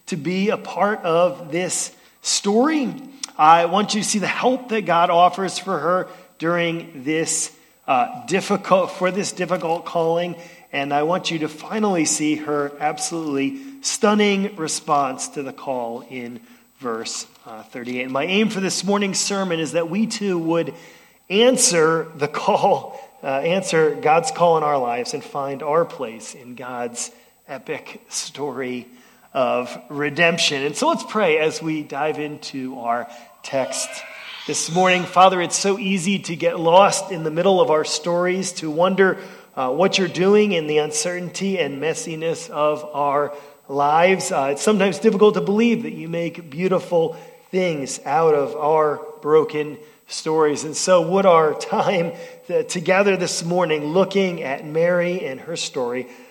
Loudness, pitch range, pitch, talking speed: -20 LUFS, 150-195 Hz, 170 Hz, 155 wpm